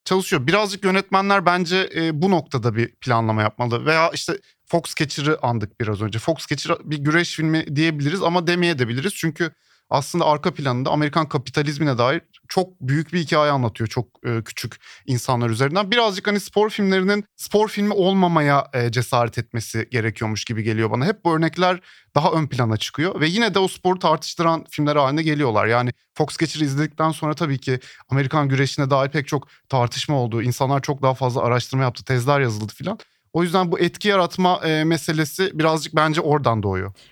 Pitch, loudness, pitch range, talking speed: 150 Hz, -21 LUFS, 125-175 Hz, 170 wpm